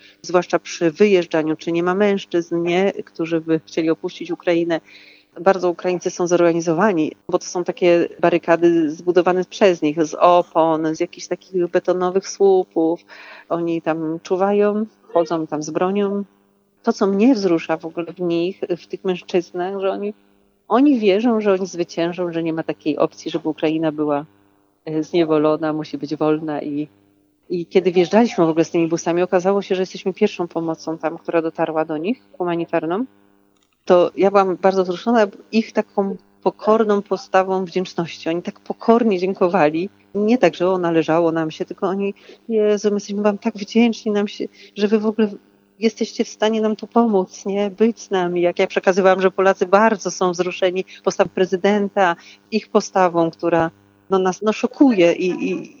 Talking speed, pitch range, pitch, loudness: 165 wpm, 165-200 Hz, 180 Hz, -19 LUFS